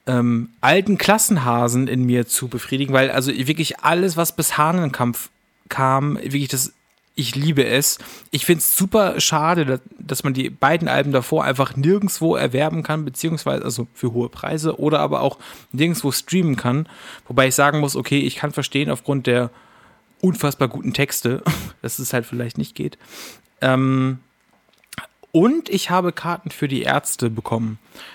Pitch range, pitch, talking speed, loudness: 130-160 Hz, 140 Hz, 160 wpm, -19 LUFS